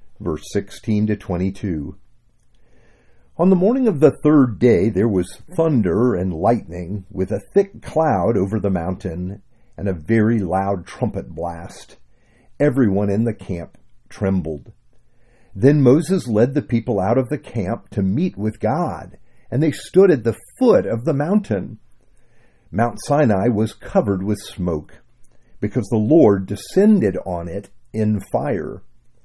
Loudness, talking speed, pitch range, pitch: -19 LUFS, 145 wpm, 95-125 Hz, 110 Hz